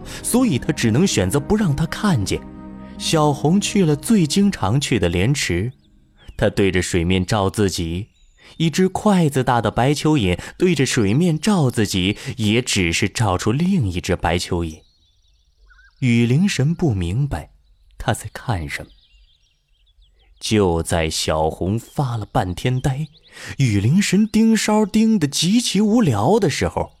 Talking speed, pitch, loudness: 205 characters per minute, 115 Hz, -19 LUFS